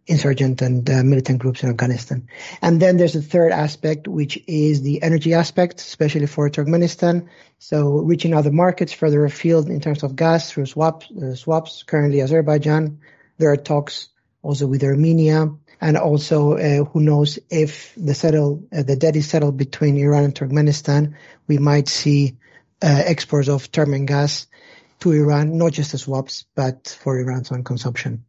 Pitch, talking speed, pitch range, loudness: 150 Hz, 170 wpm, 140-160 Hz, -18 LUFS